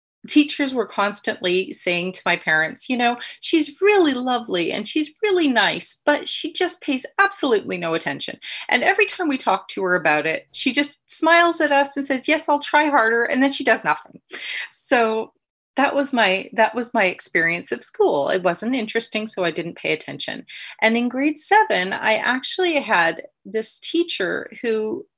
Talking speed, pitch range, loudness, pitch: 180 wpm, 215-310 Hz, -20 LUFS, 255 Hz